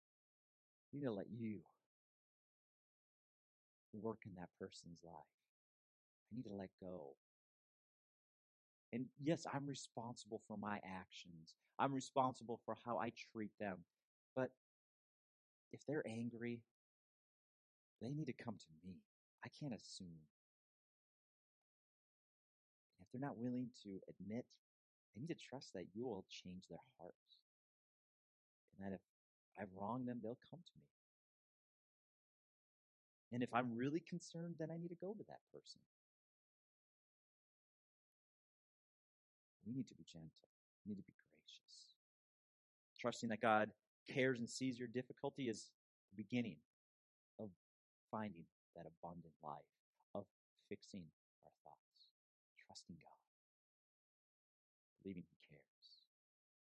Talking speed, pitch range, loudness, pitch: 120 wpm, 90-125 Hz, -48 LUFS, 110 Hz